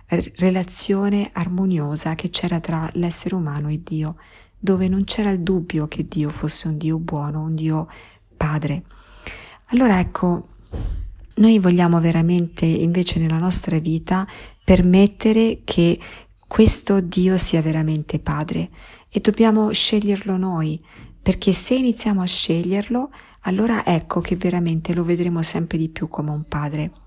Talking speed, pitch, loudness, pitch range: 135 wpm, 175 Hz, -20 LUFS, 160-190 Hz